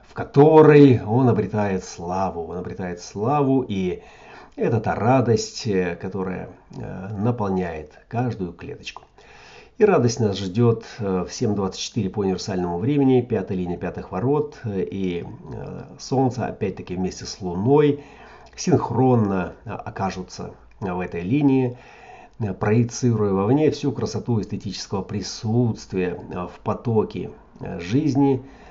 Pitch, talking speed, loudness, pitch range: 105 Hz, 100 wpm, -22 LUFS, 95-125 Hz